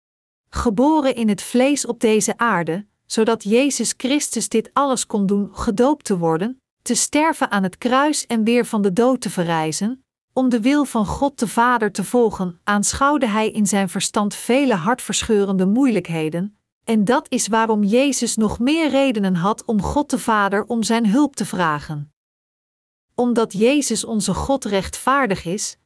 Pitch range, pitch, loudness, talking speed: 200-255 Hz, 225 Hz, -19 LUFS, 160 wpm